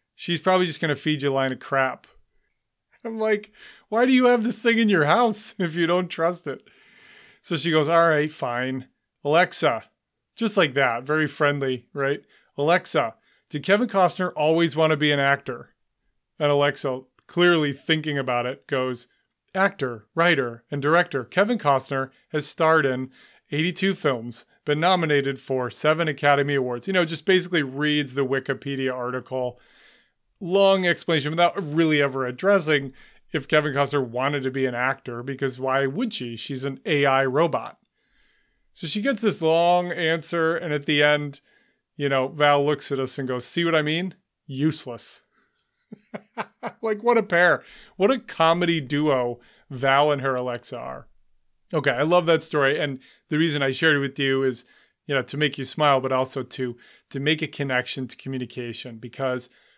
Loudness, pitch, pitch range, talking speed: -23 LUFS, 150 Hz, 135-175 Hz, 170 wpm